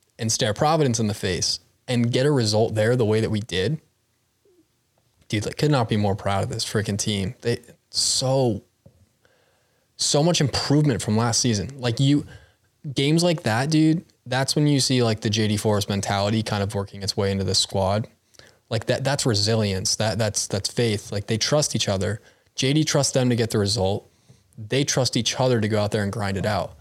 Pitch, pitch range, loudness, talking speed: 115 Hz, 105-135 Hz, -22 LUFS, 200 wpm